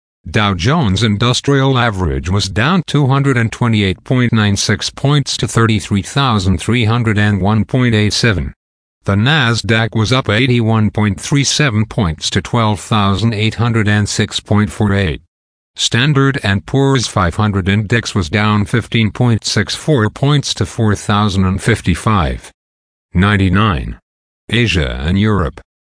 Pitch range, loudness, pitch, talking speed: 95-120 Hz, -14 LUFS, 105 Hz, 70 wpm